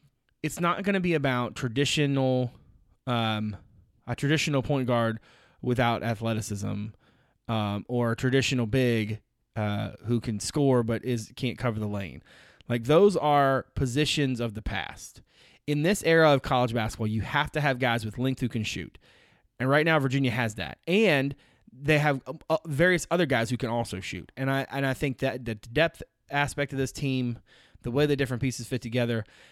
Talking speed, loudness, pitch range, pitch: 175 wpm, -27 LUFS, 115-145 Hz, 125 Hz